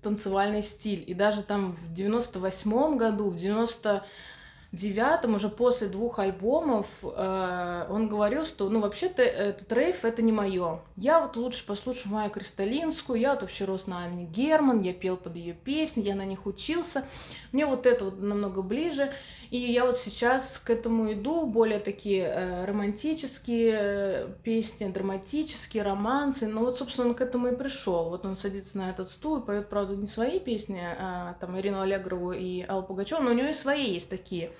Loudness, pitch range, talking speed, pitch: -29 LUFS, 195-245 Hz, 175 wpm, 210 Hz